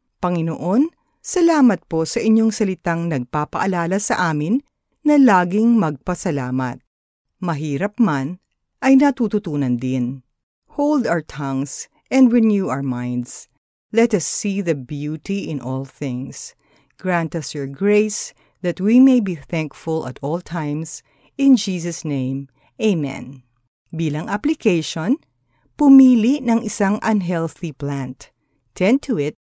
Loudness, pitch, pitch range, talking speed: -19 LUFS, 170 Hz, 145-220 Hz, 120 wpm